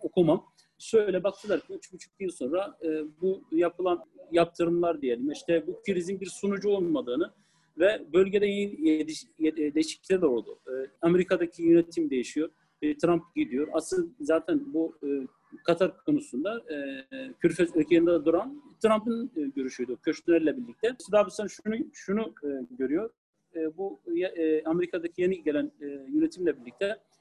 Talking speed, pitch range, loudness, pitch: 140 wpm, 155-205 Hz, -28 LUFS, 170 Hz